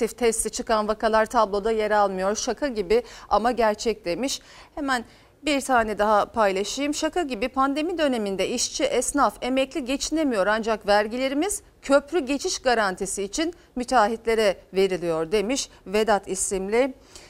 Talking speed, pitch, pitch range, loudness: 120 wpm, 230 Hz, 210-275 Hz, -24 LUFS